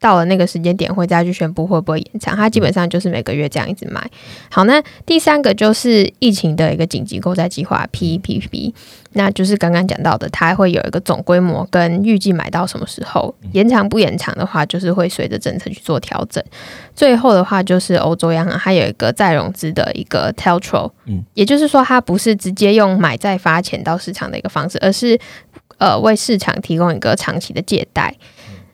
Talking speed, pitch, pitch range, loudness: 330 characters per minute, 185 Hz, 170-210 Hz, -15 LUFS